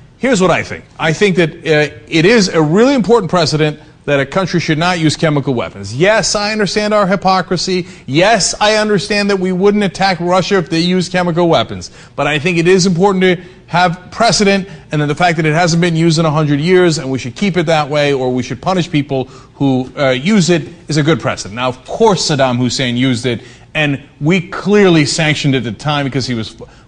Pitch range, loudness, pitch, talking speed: 140-185 Hz, -13 LUFS, 165 Hz, 220 wpm